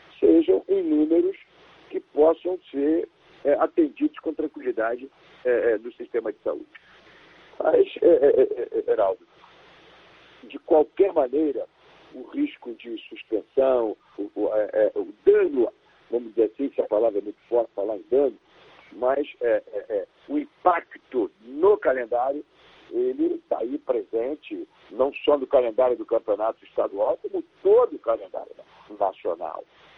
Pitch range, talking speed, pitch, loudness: 340-460 Hz, 140 wpm, 395 Hz, -24 LUFS